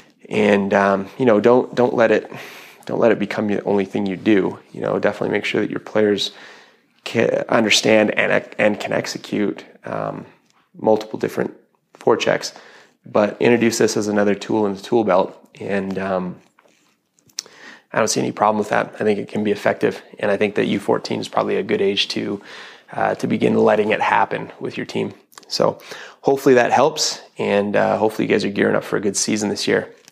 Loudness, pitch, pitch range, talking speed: -19 LUFS, 105 Hz, 100-110 Hz, 195 wpm